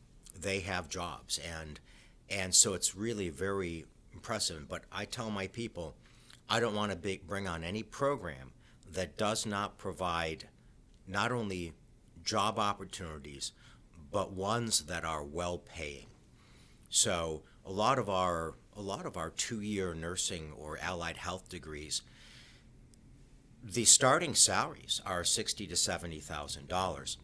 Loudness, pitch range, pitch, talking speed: -33 LUFS, 85-110 Hz, 95 Hz, 140 wpm